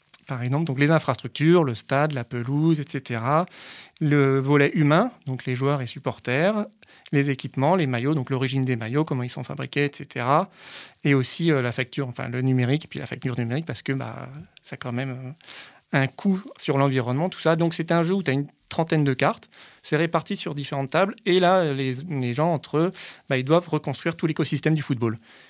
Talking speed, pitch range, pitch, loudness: 205 wpm, 130-160 Hz, 145 Hz, -24 LUFS